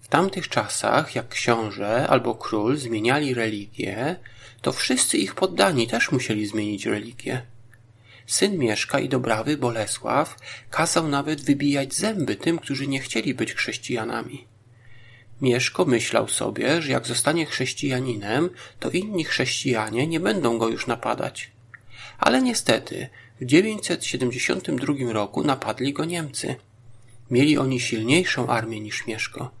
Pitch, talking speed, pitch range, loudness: 120 Hz, 125 wpm, 115-140 Hz, -23 LUFS